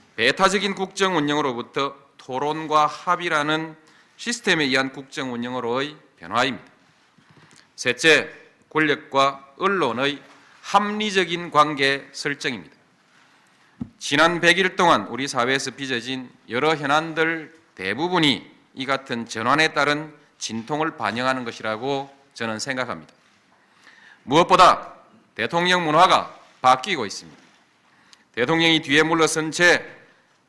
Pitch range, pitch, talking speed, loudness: 135-160 Hz, 150 Hz, 260 characters per minute, -21 LUFS